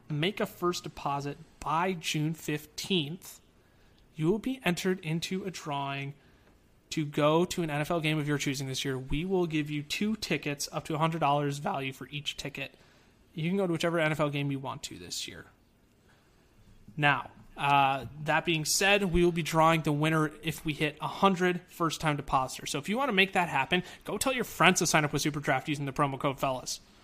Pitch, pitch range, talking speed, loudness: 155 Hz, 140-175 Hz, 200 wpm, -30 LUFS